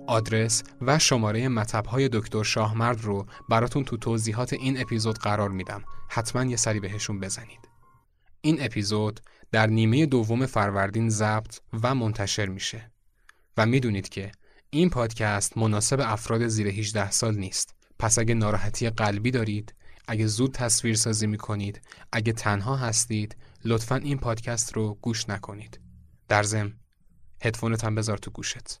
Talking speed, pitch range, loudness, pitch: 140 wpm, 105-120 Hz, -26 LUFS, 110 Hz